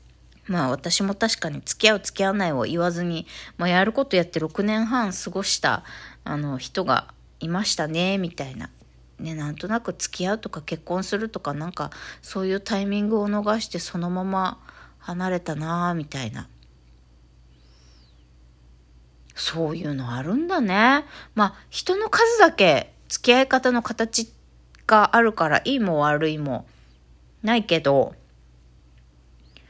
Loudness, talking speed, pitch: -23 LUFS, 270 characters per minute, 175 Hz